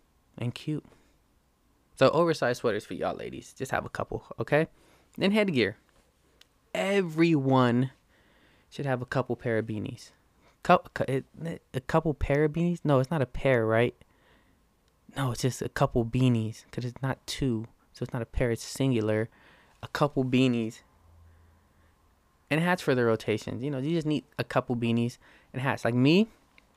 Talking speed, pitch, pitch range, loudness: 160 wpm, 125 Hz, 115-145 Hz, -28 LUFS